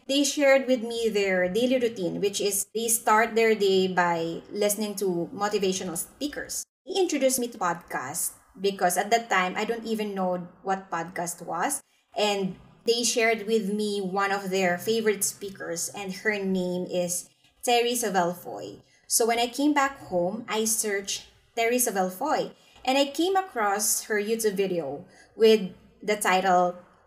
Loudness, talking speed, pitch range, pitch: -26 LUFS, 155 wpm, 185-230 Hz, 205 Hz